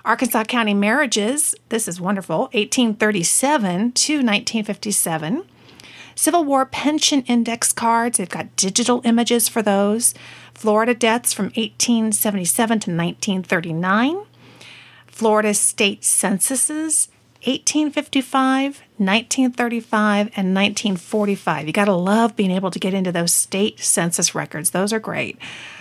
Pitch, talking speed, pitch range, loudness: 220 Hz, 110 wpm, 195-245 Hz, -18 LUFS